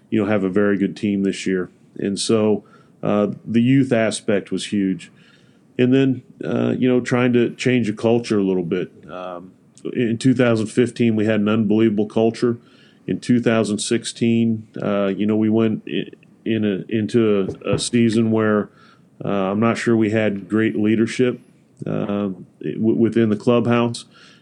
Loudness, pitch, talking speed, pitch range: -19 LUFS, 110 Hz, 160 wpm, 105-120 Hz